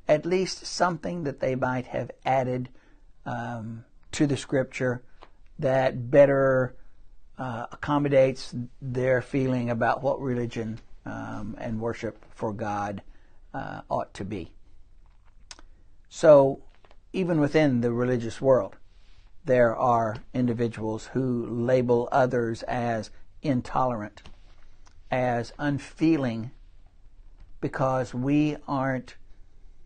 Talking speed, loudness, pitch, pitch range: 100 wpm, -26 LUFS, 120 Hz, 105-130 Hz